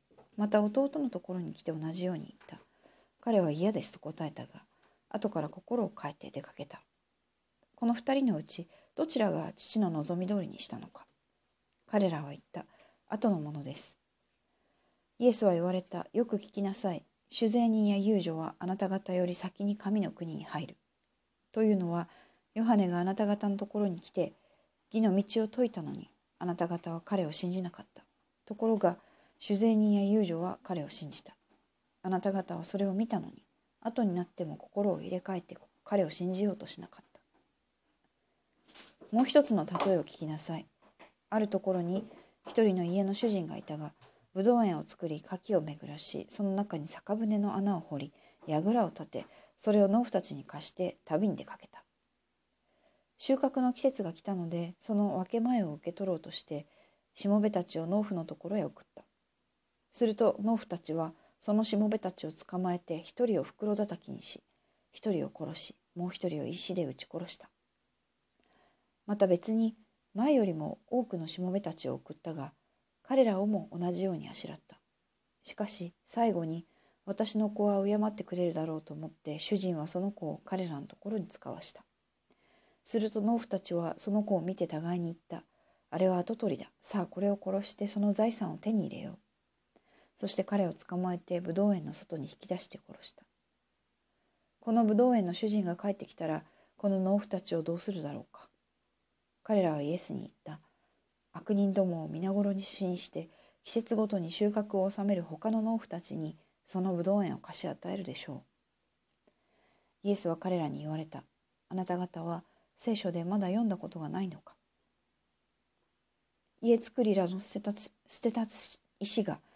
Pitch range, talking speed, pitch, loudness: 175-215 Hz, 320 characters per minute, 195 Hz, -33 LUFS